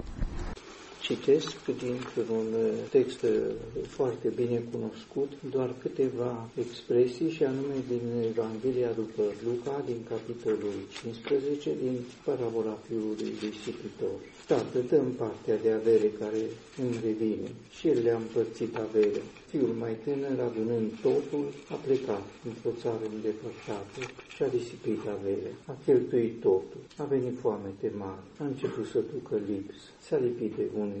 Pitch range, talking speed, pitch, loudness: 110-160 Hz, 130 wpm, 120 Hz, -31 LUFS